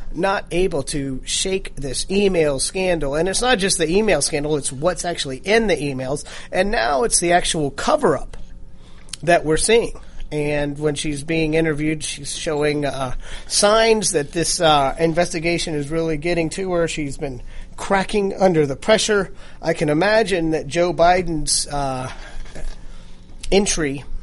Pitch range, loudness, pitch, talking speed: 145-185 Hz, -19 LUFS, 160 Hz, 155 wpm